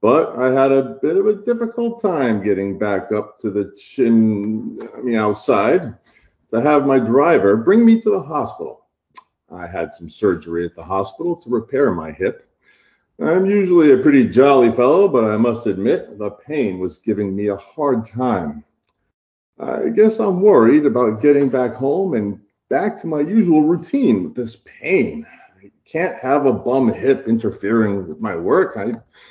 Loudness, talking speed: -17 LUFS, 170 wpm